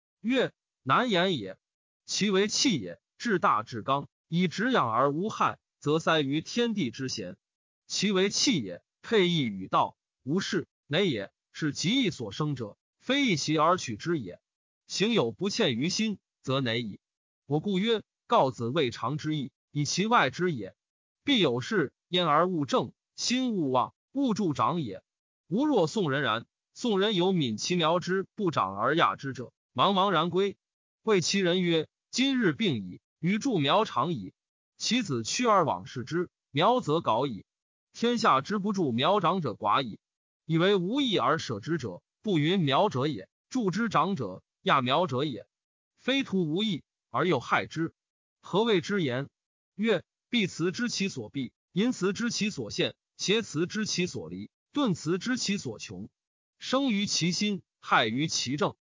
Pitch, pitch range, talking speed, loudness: 180 Hz, 150-210 Hz, 215 characters per minute, -28 LUFS